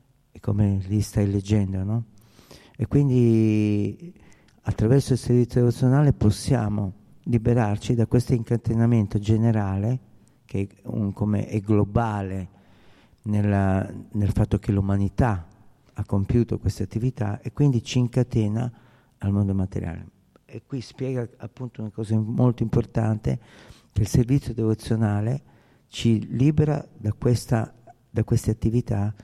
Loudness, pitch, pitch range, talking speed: -24 LUFS, 110 Hz, 105-125 Hz, 120 wpm